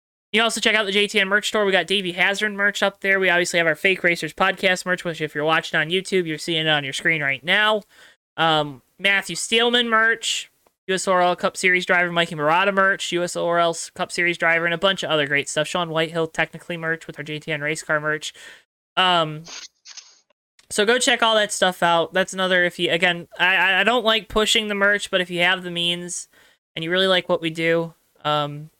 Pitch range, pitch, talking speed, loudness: 165-195 Hz, 180 Hz, 215 wpm, -20 LUFS